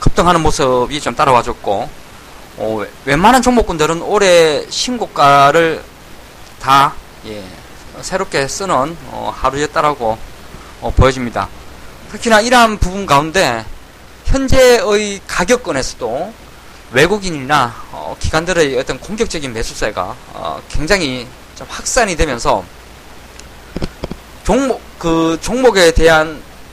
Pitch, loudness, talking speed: 155 Hz, -14 LUFS, 235 characters per minute